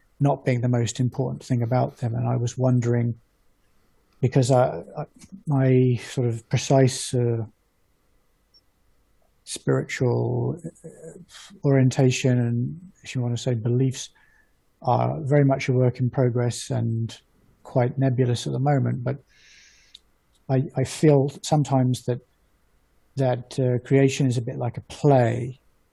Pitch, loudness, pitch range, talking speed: 125 Hz, -23 LUFS, 120-135 Hz, 125 wpm